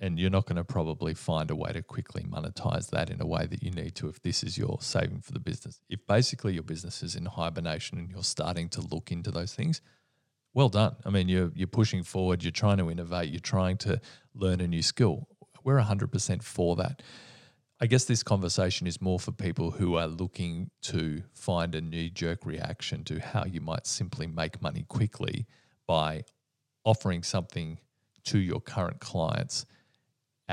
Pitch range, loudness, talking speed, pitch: 85-125 Hz, -31 LUFS, 195 wpm, 95 Hz